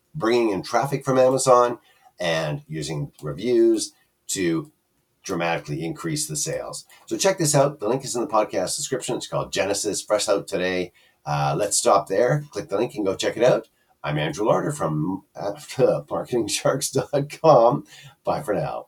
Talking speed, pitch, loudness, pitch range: 160 wpm, 135 Hz, -23 LUFS, 95-155 Hz